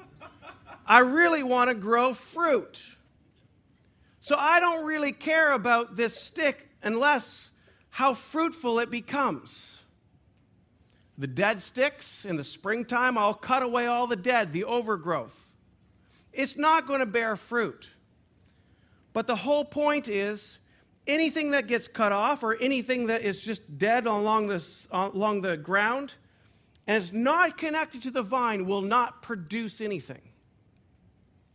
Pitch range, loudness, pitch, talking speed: 200-270 Hz, -26 LUFS, 235 Hz, 135 wpm